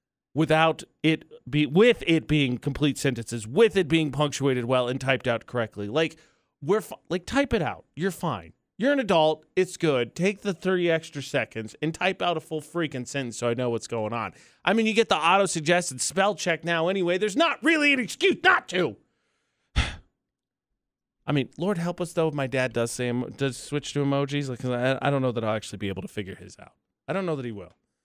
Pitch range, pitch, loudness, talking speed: 125-180 Hz, 155 Hz, -25 LUFS, 220 wpm